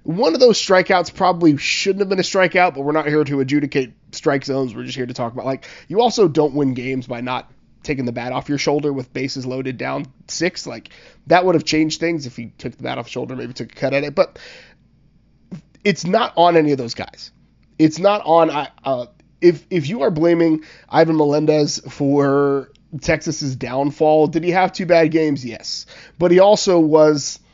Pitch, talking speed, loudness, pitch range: 150 Hz, 210 wpm, -18 LUFS, 135-170 Hz